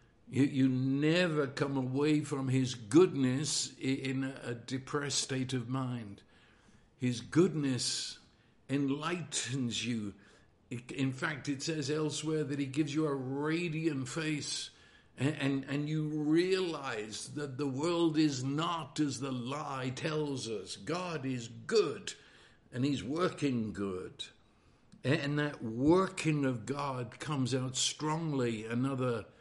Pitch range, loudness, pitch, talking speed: 130-155 Hz, -34 LUFS, 140 Hz, 120 wpm